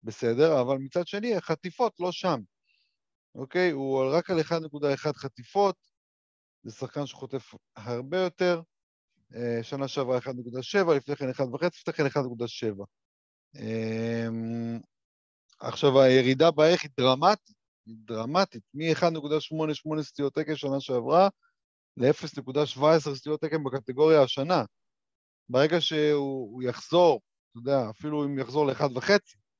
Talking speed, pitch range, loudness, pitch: 115 wpm, 125-160 Hz, -27 LUFS, 140 Hz